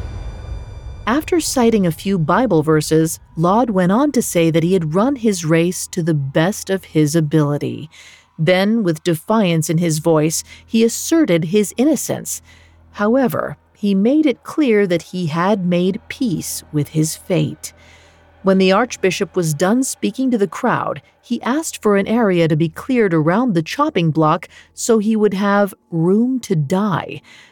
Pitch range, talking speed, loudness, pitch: 165-225 Hz, 160 wpm, -17 LUFS, 190 Hz